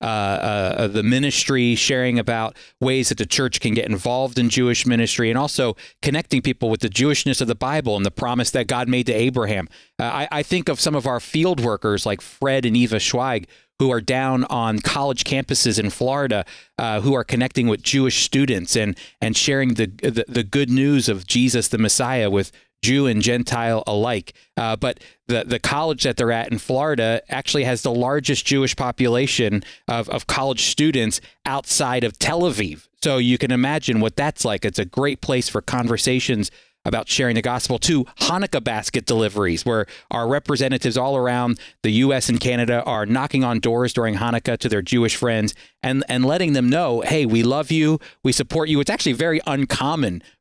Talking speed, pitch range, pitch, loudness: 190 wpm, 115-135 Hz, 125 Hz, -20 LUFS